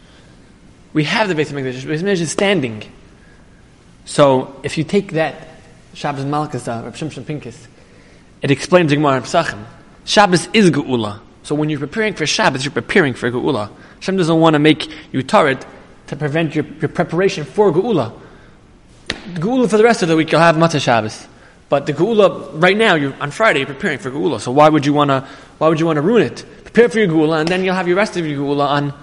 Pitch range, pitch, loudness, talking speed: 140-180 Hz, 155 Hz, -16 LUFS, 195 wpm